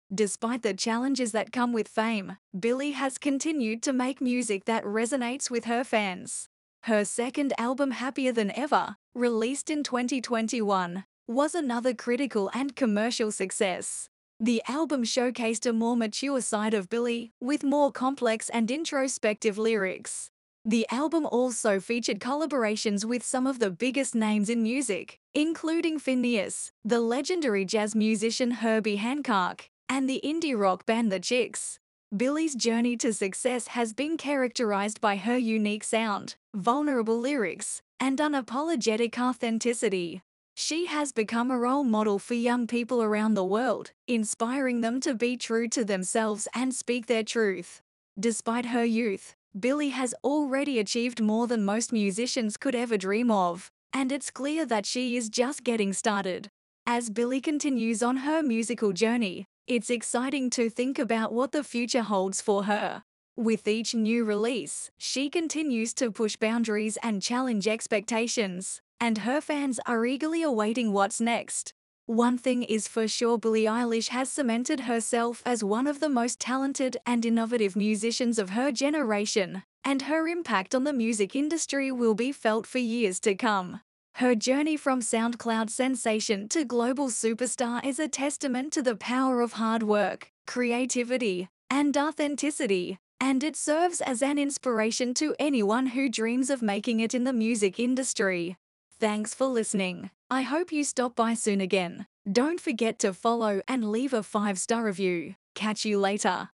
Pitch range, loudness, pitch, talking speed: 220-260 Hz, -28 LUFS, 235 Hz, 155 wpm